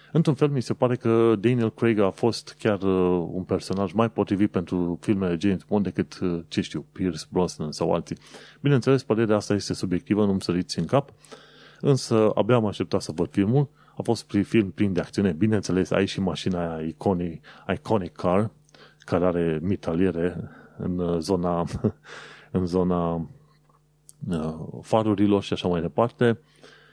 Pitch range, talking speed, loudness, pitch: 90-115 Hz, 160 wpm, -25 LUFS, 100 Hz